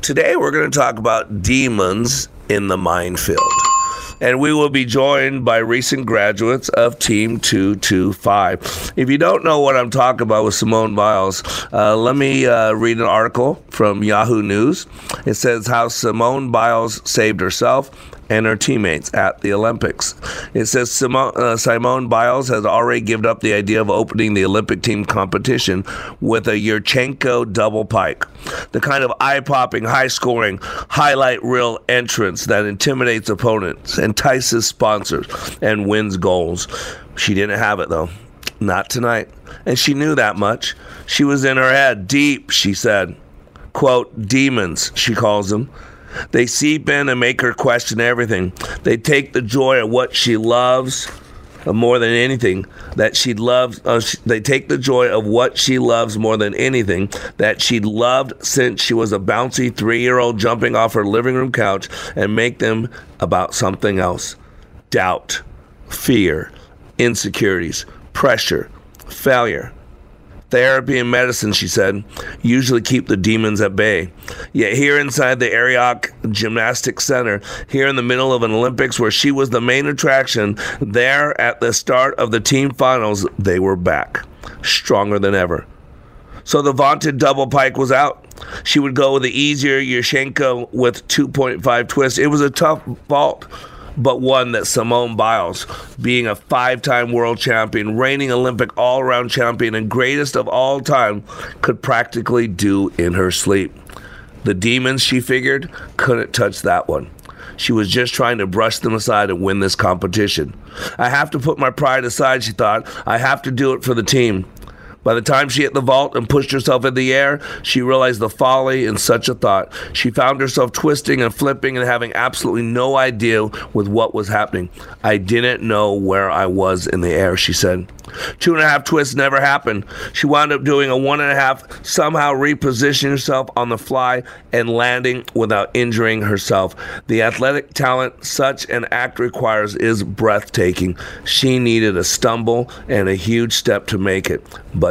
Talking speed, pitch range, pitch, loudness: 170 wpm, 105-130 Hz, 120 Hz, -16 LUFS